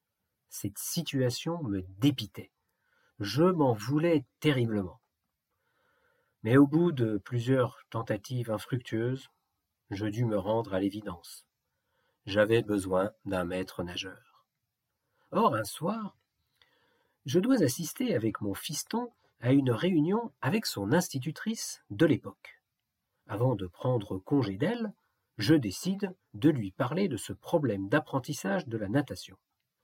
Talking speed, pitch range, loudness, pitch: 120 wpm, 105-155 Hz, -30 LUFS, 125 Hz